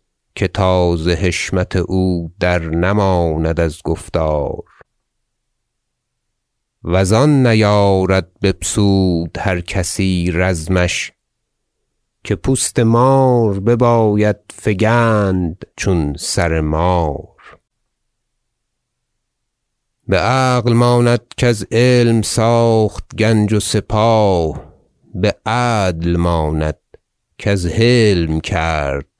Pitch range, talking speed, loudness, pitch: 90-120 Hz, 80 wpm, -15 LUFS, 105 Hz